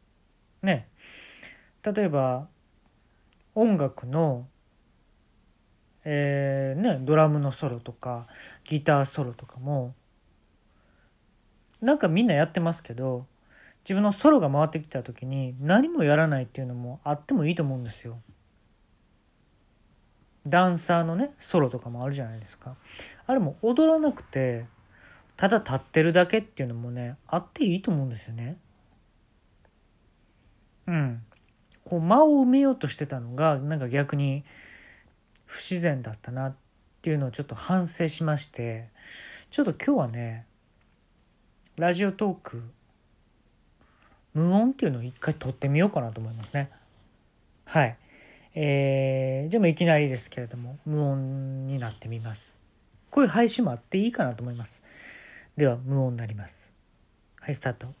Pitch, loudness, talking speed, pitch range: 135 Hz, -26 LUFS, 290 characters per minute, 115-165 Hz